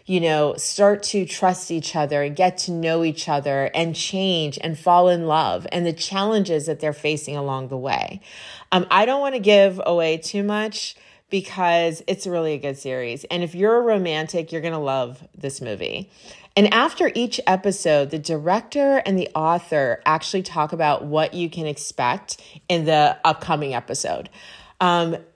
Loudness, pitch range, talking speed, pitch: -21 LUFS, 155-190 Hz, 180 wpm, 170 Hz